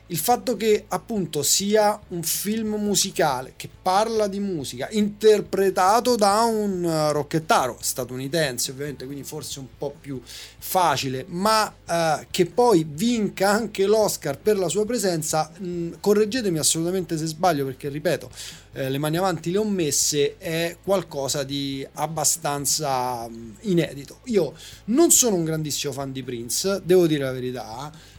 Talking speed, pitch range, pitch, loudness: 145 wpm, 140-200 Hz, 165 Hz, -22 LUFS